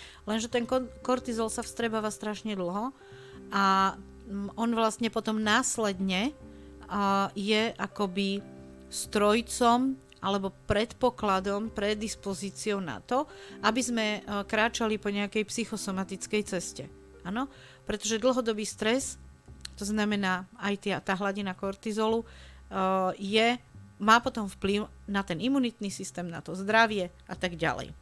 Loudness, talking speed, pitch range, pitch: -29 LUFS, 110 wpm, 195-225 Hz, 205 Hz